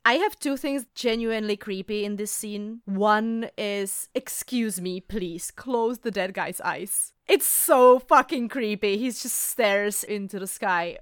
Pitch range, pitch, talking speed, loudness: 200-240 Hz, 215 Hz, 160 wpm, -25 LUFS